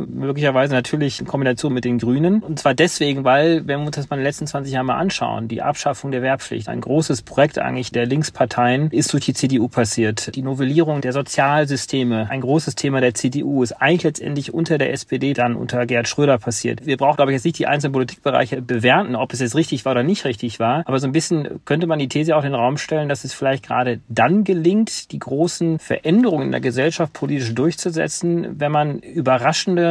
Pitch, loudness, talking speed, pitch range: 140 Hz, -19 LUFS, 215 wpm, 130-155 Hz